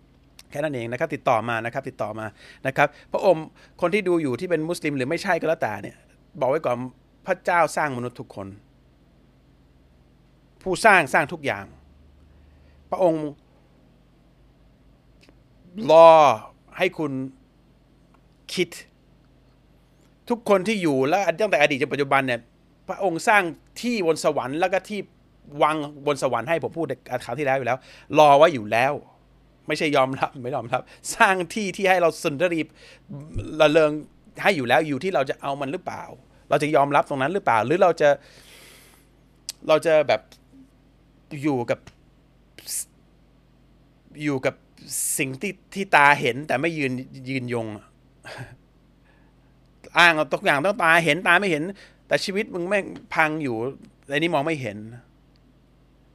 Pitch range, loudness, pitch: 130-170 Hz, -22 LUFS, 150 Hz